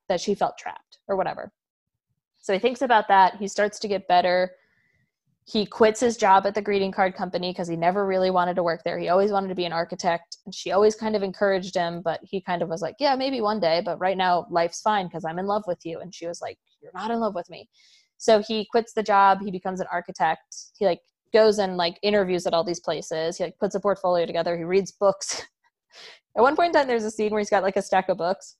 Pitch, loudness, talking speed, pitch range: 190 Hz, -24 LUFS, 255 wpm, 175-210 Hz